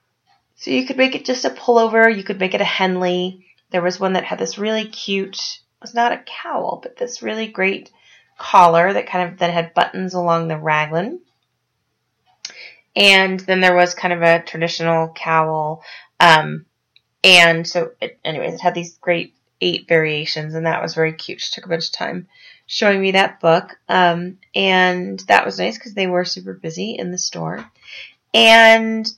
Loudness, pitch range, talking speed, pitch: -16 LUFS, 165-210 Hz, 185 wpm, 180 Hz